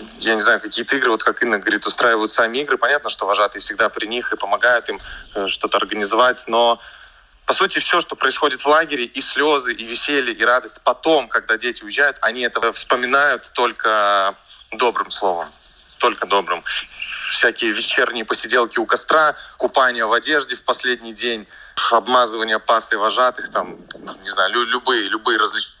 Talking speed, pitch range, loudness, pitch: 160 wpm, 115-125 Hz, -18 LUFS, 120 Hz